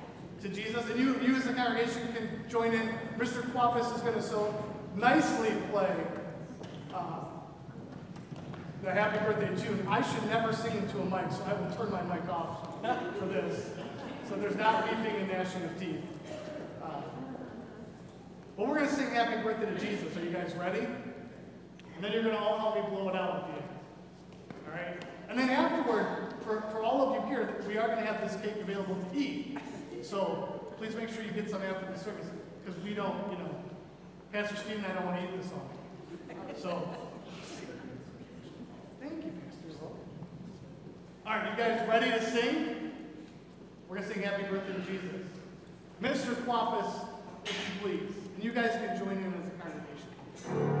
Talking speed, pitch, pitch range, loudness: 180 wpm, 210 Hz, 185-225 Hz, -34 LUFS